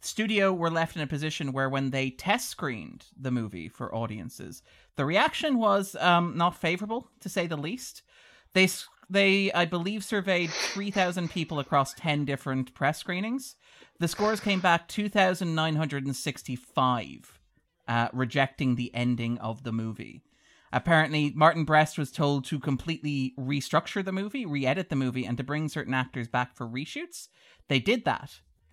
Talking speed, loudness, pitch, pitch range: 165 wpm, -28 LUFS, 155 Hz, 130-185 Hz